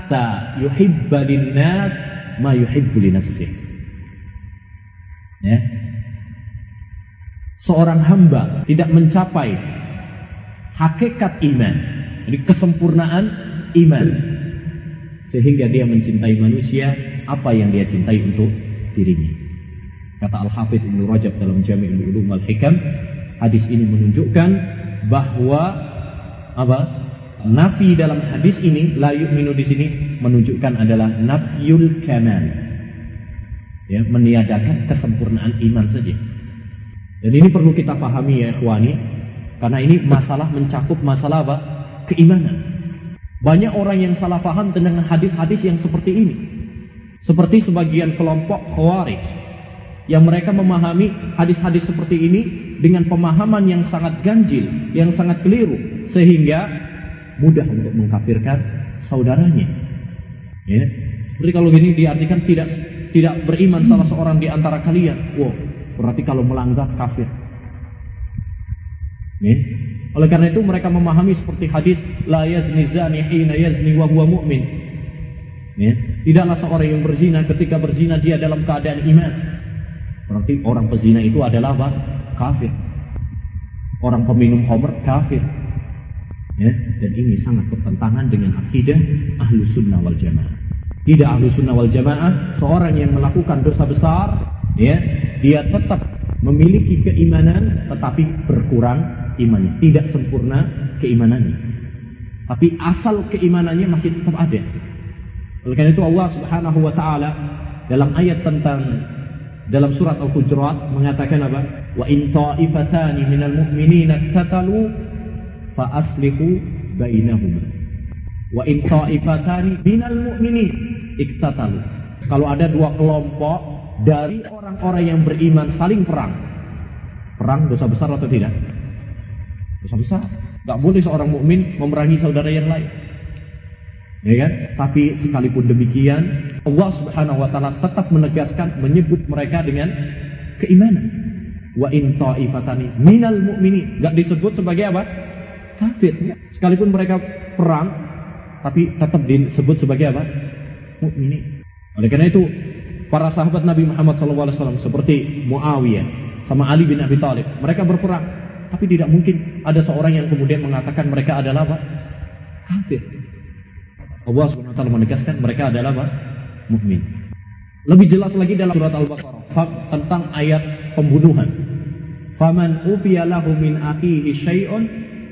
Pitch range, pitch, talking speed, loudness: 115-165 Hz, 145 Hz, 110 wpm, -16 LUFS